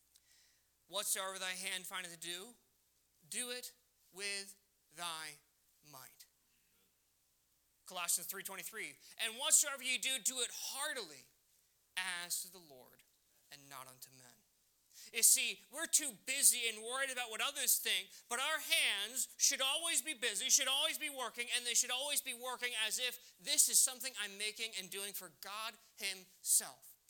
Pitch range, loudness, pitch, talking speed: 170-255 Hz, -35 LUFS, 205 Hz, 150 wpm